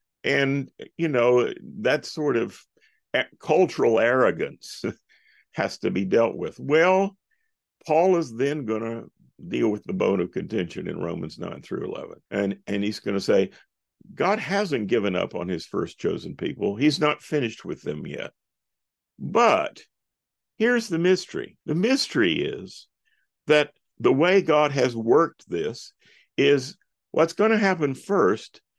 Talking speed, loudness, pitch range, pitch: 150 wpm, -24 LUFS, 130-200 Hz, 160 Hz